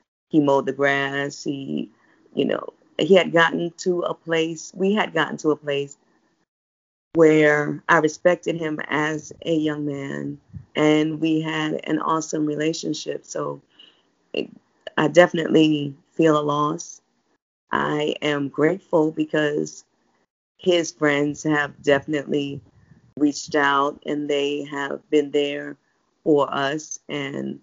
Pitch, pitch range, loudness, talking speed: 150 Hz, 140-155 Hz, -22 LUFS, 125 wpm